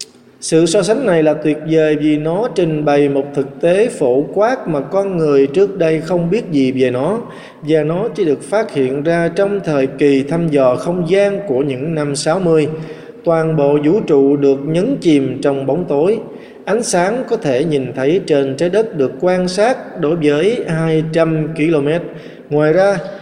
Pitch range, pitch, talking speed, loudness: 145-175 Hz, 155 Hz, 185 wpm, -15 LUFS